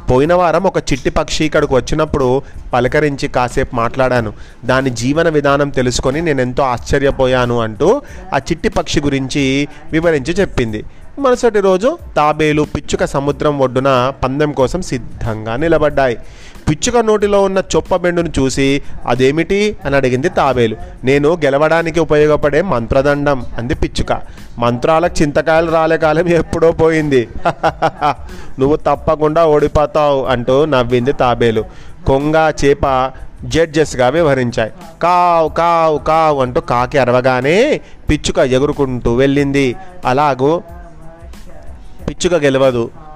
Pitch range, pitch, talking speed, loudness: 130-160 Hz, 145 Hz, 105 wpm, -14 LUFS